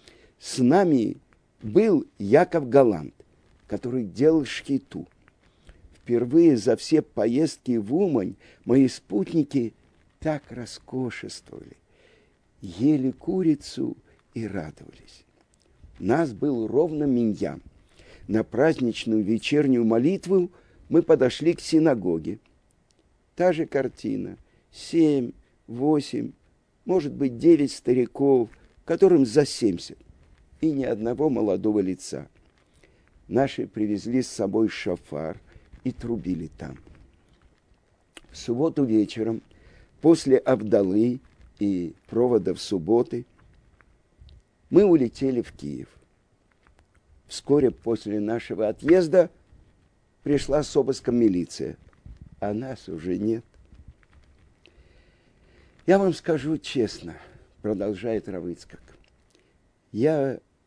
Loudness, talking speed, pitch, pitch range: -24 LUFS, 90 wpm, 115 Hz, 95-140 Hz